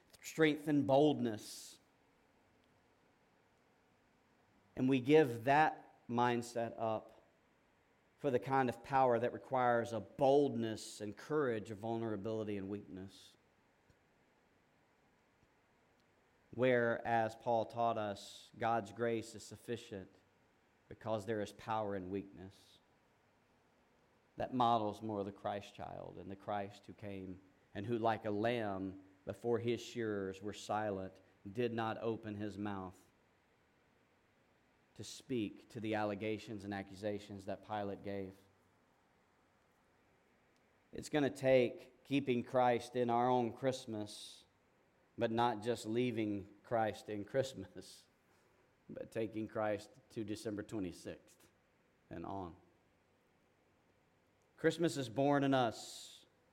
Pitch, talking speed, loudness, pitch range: 110 Hz, 110 wpm, -38 LUFS, 100-120 Hz